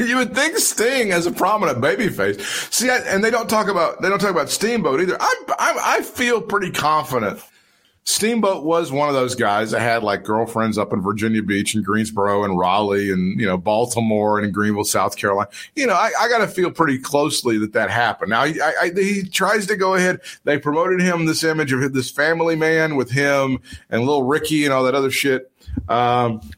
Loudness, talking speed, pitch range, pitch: -19 LUFS, 210 wpm, 110-180 Hz, 135 Hz